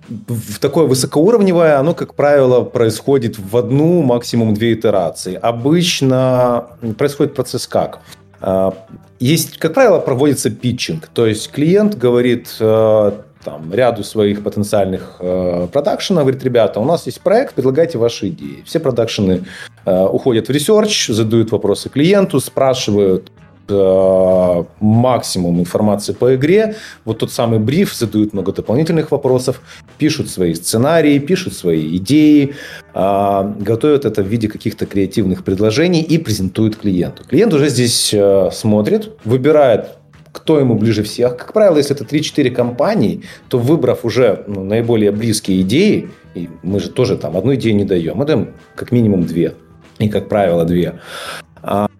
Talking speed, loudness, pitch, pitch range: 135 wpm, -14 LUFS, 115 Hz, 100-140 Hz